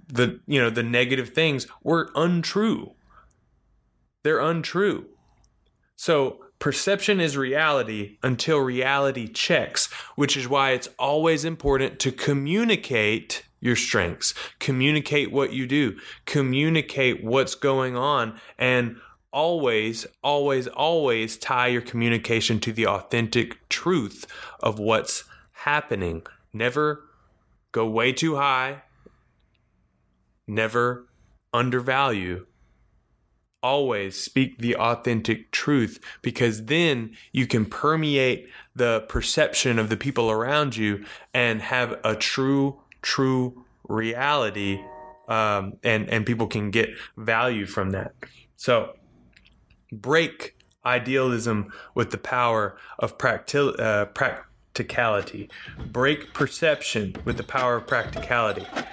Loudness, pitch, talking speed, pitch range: -24 LUFS, 125 Hz, 105 wpm, 110-140 Hz